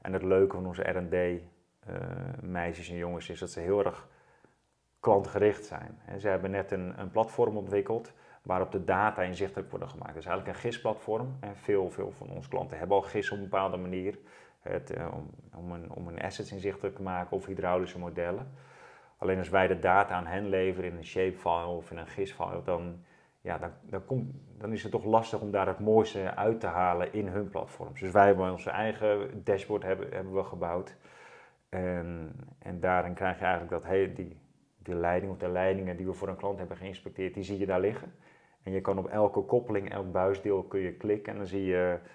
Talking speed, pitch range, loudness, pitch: 210 wpm, 90-100 Hz, -32 LUFS, 95 Hz